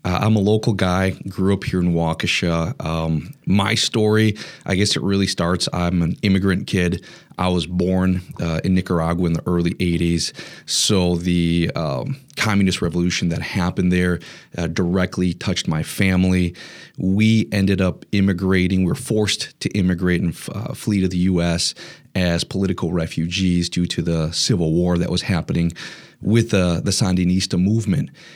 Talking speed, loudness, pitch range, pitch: 155 wpm, -20 LUFS, 85-100 Hz, 90 Hz